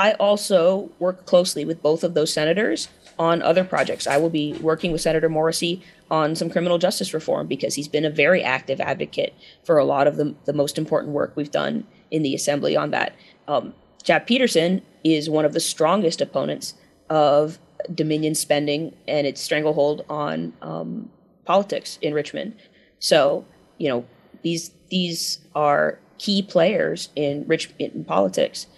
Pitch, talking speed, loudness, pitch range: 160 Hz, 165 wpm, -22 LUFS, 150-180 Hz